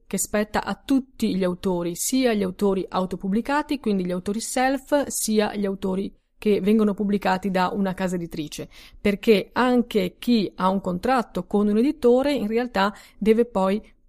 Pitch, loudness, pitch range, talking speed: 205 Hz, -23 LUFS, 190-235 Hz, 160 wpm